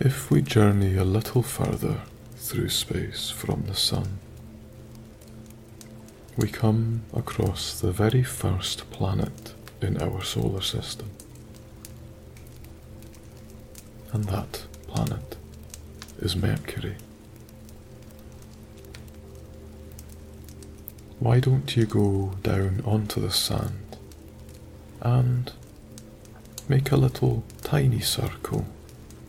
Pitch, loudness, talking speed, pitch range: 110 Hz, -26 LUFS, 85 wpm, 100-115 Hz